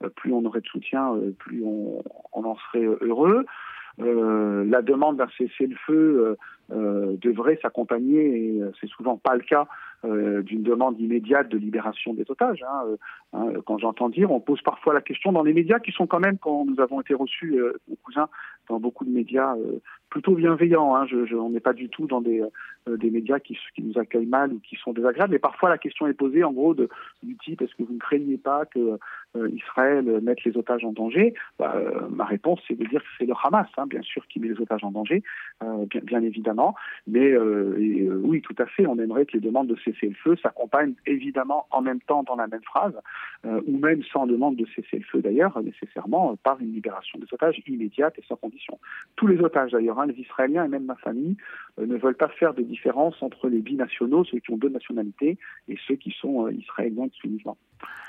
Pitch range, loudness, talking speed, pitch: 115-150 Hz, -24 LUFS, 230 wpm, 130 Hz